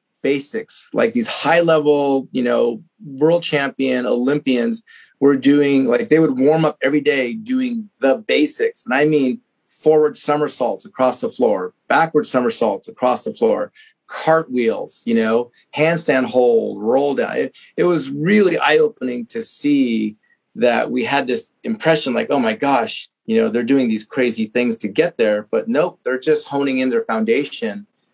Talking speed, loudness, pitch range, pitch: 165 wpm, -18 LUFS, 130-215 Hz, 150 Hz